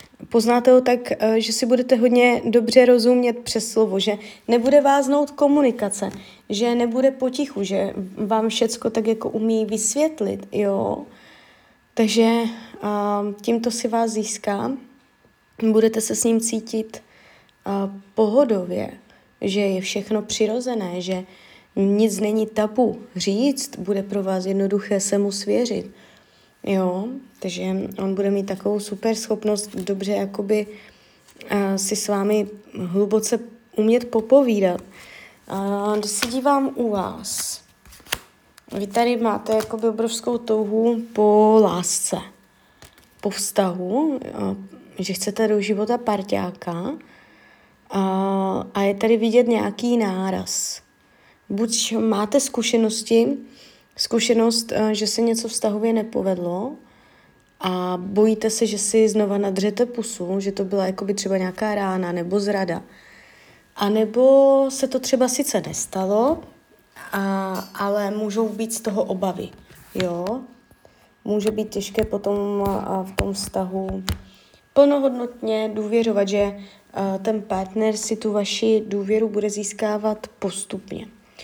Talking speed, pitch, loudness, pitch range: 120 wpm, 215 Hz, -21 LUFS, 200-230 Hz